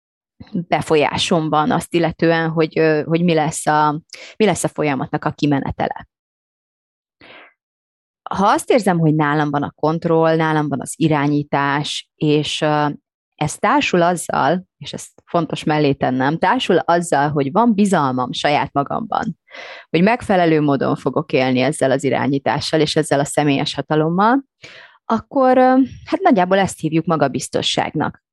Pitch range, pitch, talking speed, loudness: 145-170 Hz, 155 Hz, 130 wpm, -17 LUFS